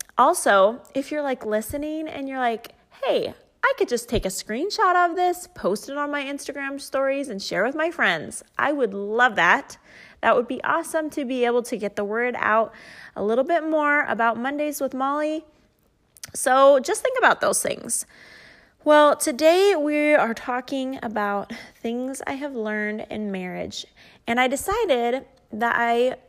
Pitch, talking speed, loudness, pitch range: 270 Hz, 170 wpm, -22 LUFS, 230-300 Hz